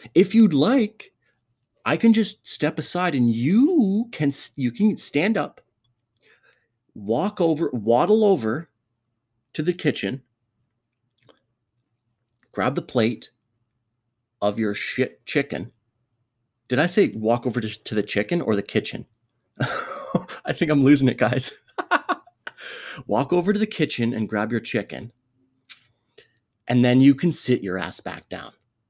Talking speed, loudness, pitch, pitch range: 135 wpm, -22 LUFS, 125 Hz, 115-170 Hz